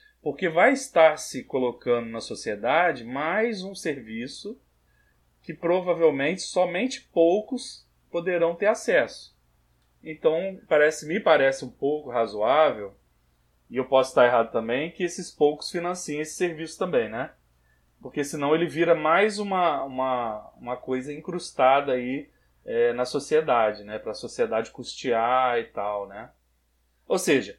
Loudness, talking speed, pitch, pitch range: -25 LUFS, 135 wpm, 155 Hz, 120-180 Hz